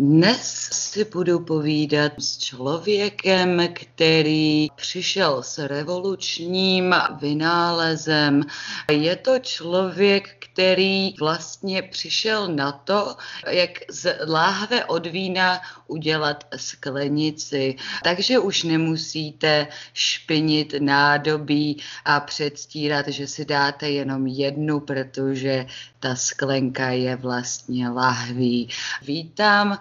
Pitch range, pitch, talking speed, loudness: 140-180 Hz, 155 Hz, 90 wpm, -22 LUFS